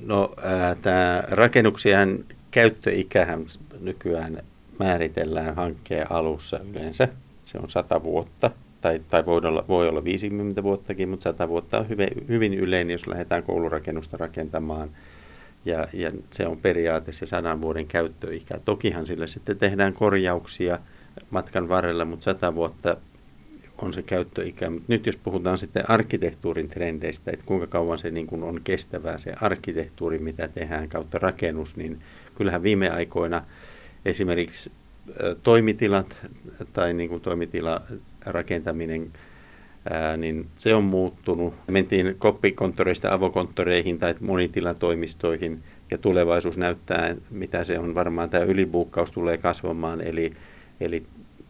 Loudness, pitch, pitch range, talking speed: -25 LUFS, 85 Hz, 80-95 Hz, 125 wpm